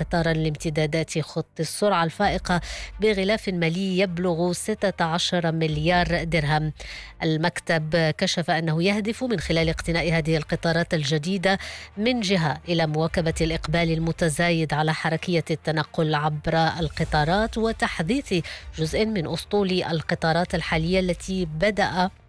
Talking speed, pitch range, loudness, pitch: 105 wpm, 160-185 Hz, -24 LUFS, 170 Hz